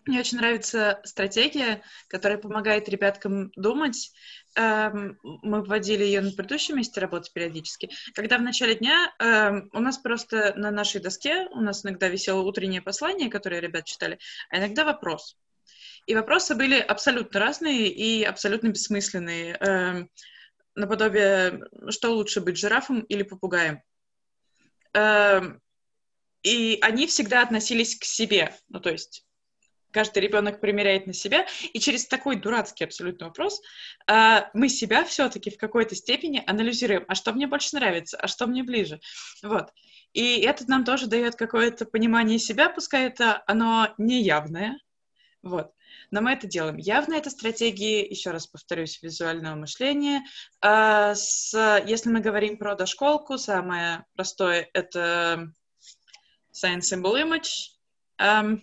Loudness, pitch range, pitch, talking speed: -24 LUFS, 195-240 Hz, 215 Hz, 130 wpm